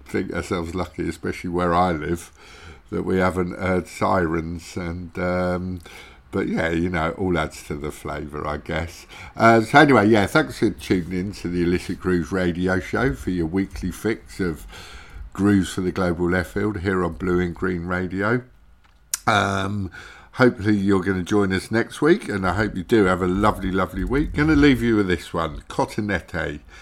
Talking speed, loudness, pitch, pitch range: 185 wpm, -22 LUFS, 90 Hz, 85-100 Hz